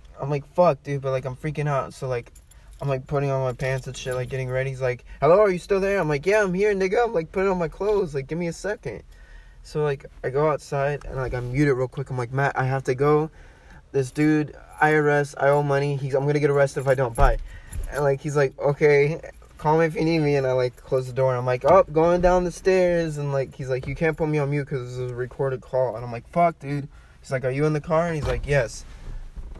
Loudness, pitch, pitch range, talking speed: -23 LUFS, 140 Hz, 130-155 Hz, 280 wpm